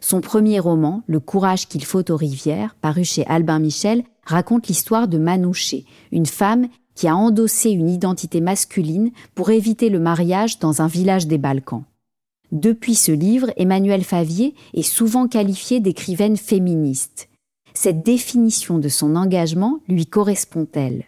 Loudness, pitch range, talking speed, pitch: -18 LUFS, 160-220 Hz, 150 wpm, 185 Hz